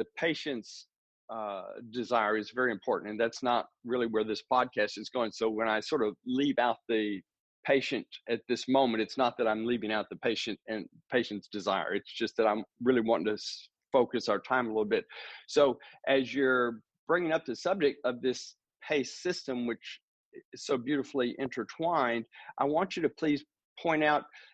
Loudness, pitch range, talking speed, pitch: -31 LUFS, 110-135 Hz, 185 wpm, 125 Hz